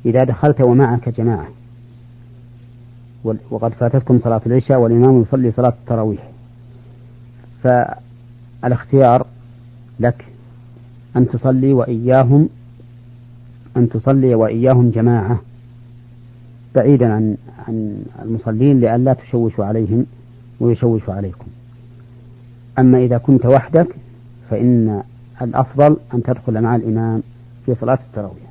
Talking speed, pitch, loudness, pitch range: 90 wpm, 120 Hz, -15 LUFS, 120-125 Hz